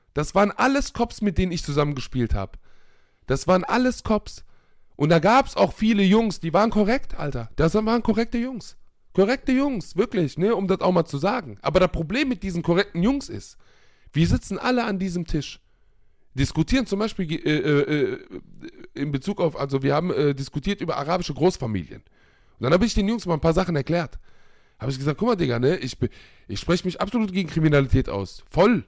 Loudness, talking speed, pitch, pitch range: -23 LUFS, 195 wpm, 175 Hz, 140-215 Hz